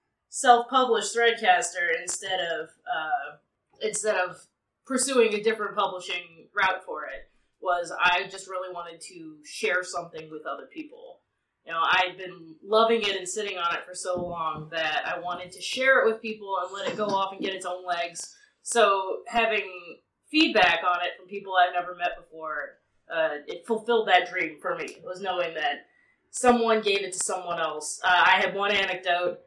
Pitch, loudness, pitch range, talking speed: 190 Hz, -26 LUFS, 175-225 Hz, 185 wpm